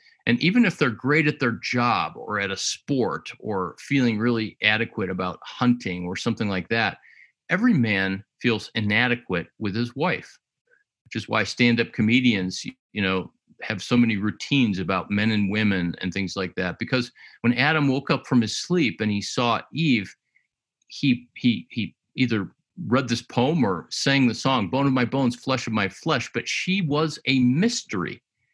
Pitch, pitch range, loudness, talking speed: 120 Hz, 105-135 Hz, -23 LUFS, 175 wpm